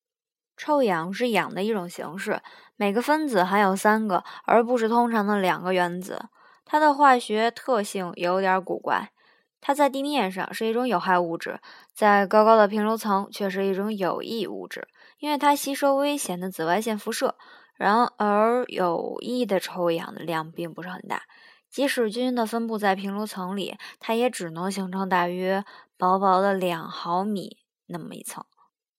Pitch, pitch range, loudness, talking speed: 210 Hz, 185-245 Hz, -24 LUFS, 250 characters per minute